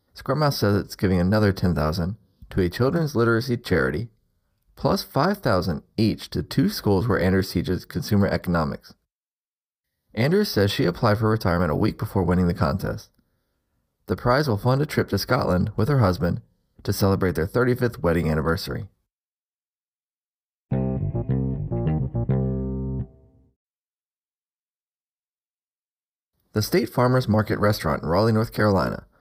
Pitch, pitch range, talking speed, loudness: 100 Hz, 85-115 Hz, 125 wpm, -23 LUFS